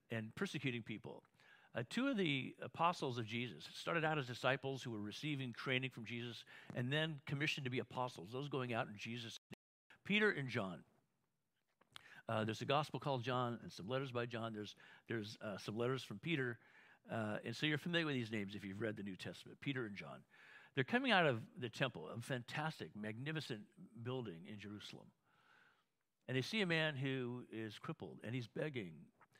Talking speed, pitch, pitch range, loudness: 190 wpm, 125 Hz, 115-150 Hz, -43 LUFS